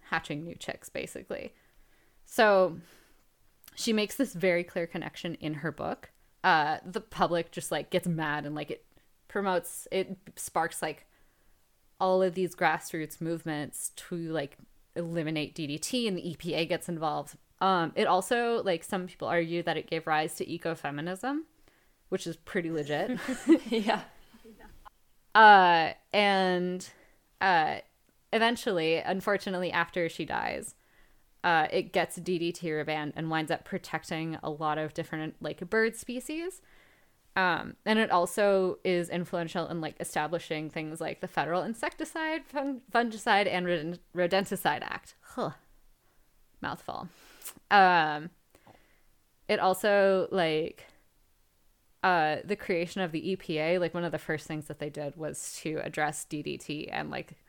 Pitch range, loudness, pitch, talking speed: 160-195 Hz, -30 LUFS, 175 Hz, 135 wpm